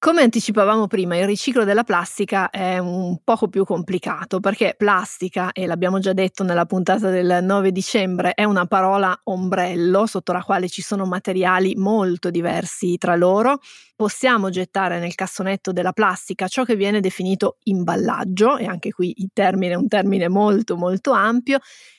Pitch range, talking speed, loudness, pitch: 185-205 Hz, 160 wpm, -19 LUFS, 190 Hz